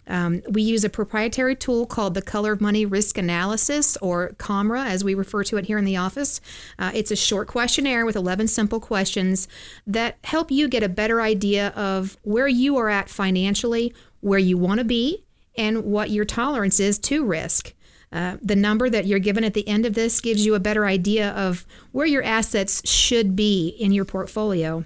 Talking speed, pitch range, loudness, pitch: 200 wpm, 195-230 Hz, -21 LUFS, 210 Hz